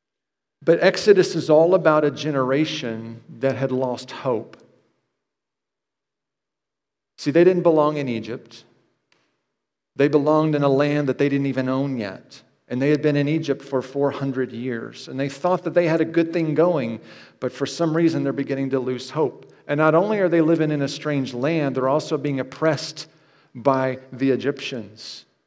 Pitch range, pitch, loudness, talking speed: 130-160 Hz, 145 Hz, -21 LUFS, 170 wpm